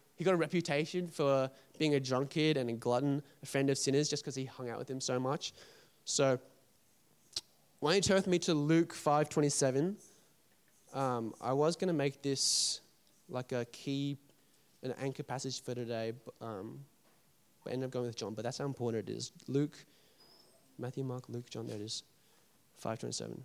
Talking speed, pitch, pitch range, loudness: 190 wpm, 135 Hz, 125-150 Hz, -35 LUFS